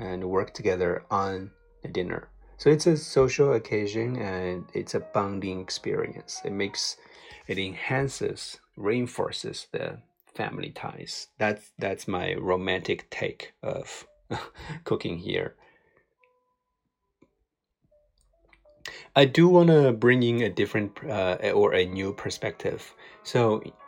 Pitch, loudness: 120 Hz, -27 LUFS